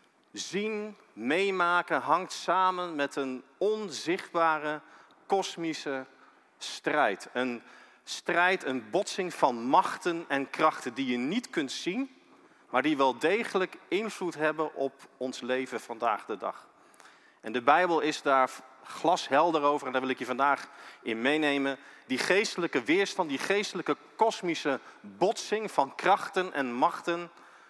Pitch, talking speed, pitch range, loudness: 160 Hz, 130 wpm, 135-190 Hz, -29 LUFS